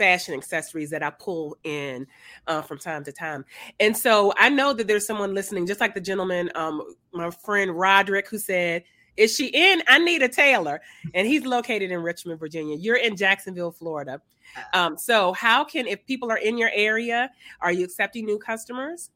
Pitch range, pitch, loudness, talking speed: 170-230 Hz, 195 Hz, -22 LUFS, 190 wpm